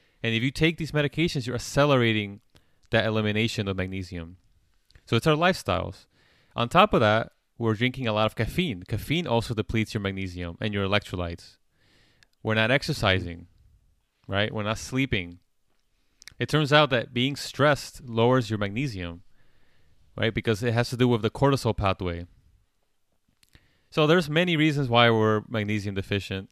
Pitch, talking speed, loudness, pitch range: 110 Hz, 155 wpm, -25 LUFS, 95-130 Hz